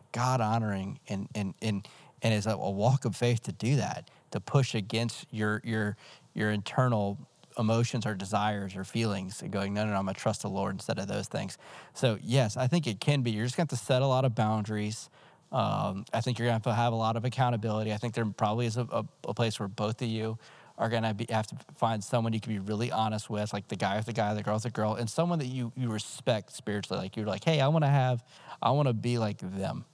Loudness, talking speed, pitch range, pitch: -31 LUFS, 255 wpm, 105-125 Hz, 110 Hz